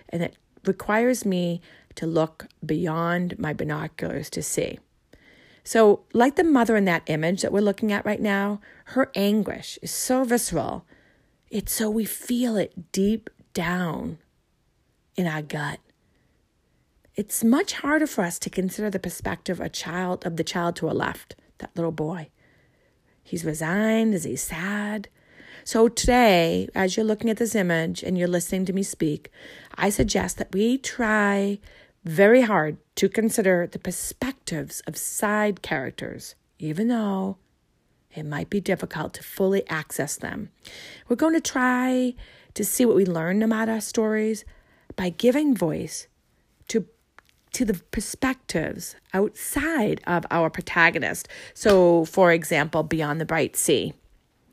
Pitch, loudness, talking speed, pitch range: 200 Hz, -24 LUFS, 145 wpm, 170-225 Hz